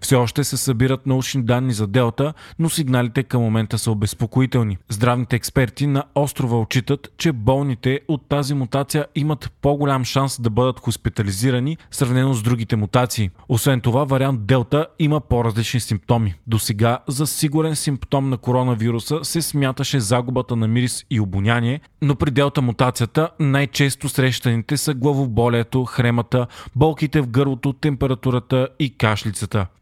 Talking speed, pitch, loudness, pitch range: 140 wpm, 130 Hz, -20 LUFS, 120-140 Hz